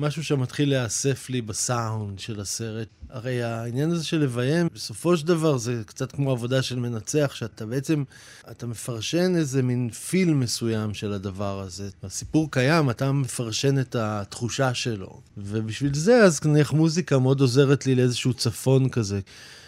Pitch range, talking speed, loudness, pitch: 115-145 Hz, 150 wpm, -24 LUFS, 125 Hz